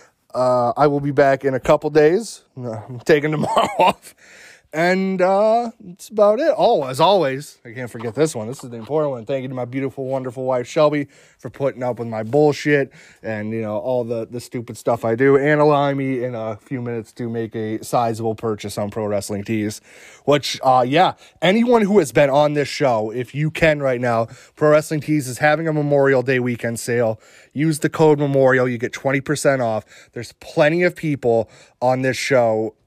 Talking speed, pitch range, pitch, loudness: 205 wpm, 120-150 Hz, 130 Hz, -19 LUFS